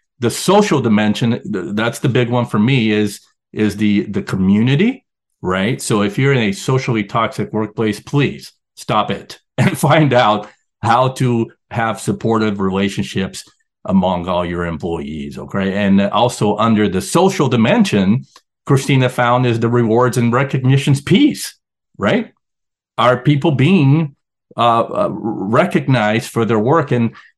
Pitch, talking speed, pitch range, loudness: 115 Hz, 140 wpm, 105-135 Hz, -15 LUFS